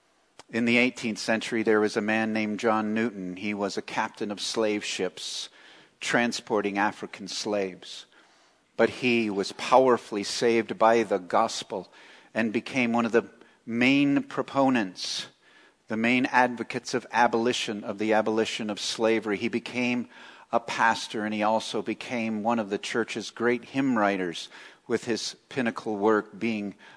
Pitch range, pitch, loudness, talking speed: 105-120 Hz, 115 Hz, -27 LUFS, 145 wpm